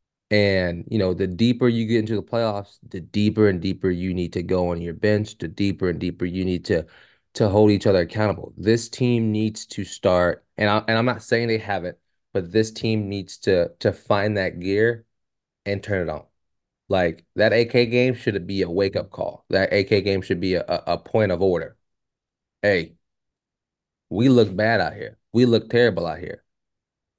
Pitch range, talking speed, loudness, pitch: 95-115 Hz, 195 wpm, -22 LUFS, 105 Hz